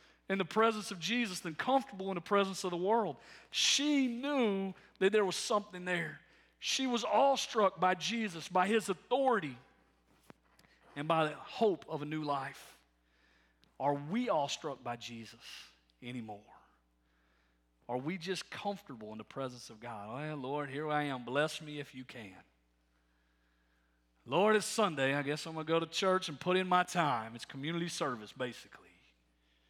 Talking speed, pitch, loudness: 170 wpm, 150 Hz, -34 LUFS